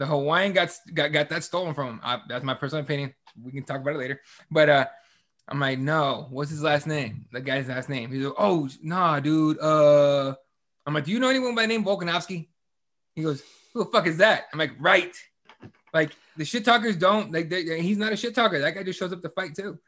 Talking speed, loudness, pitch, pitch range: 235 wpm, -24 LUFS, 155 Hz, 140-185 Hz